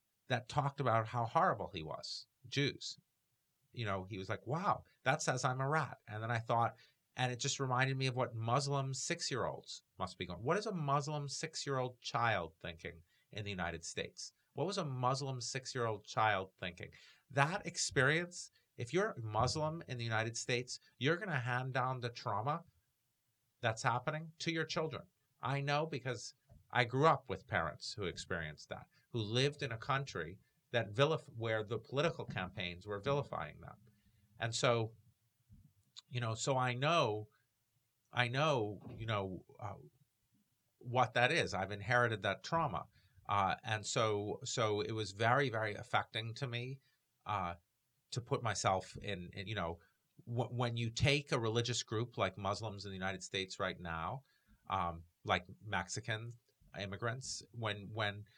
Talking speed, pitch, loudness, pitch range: 160 wpm, 120 Hz, -38 LUFS, 105-135 Hz